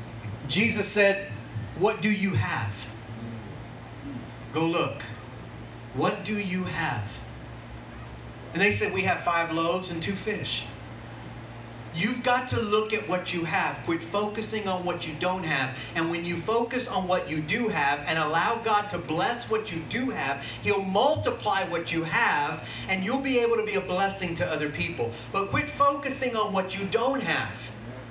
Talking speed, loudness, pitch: 170 wpm, -27 LUFS, 170 Hz